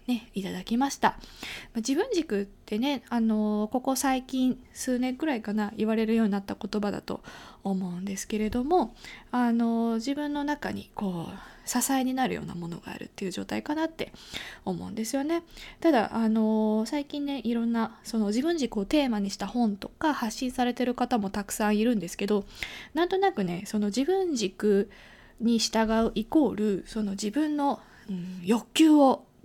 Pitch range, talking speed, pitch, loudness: 210-265 Hz, 330 characters per minute, 230 Hz, -28 LUFS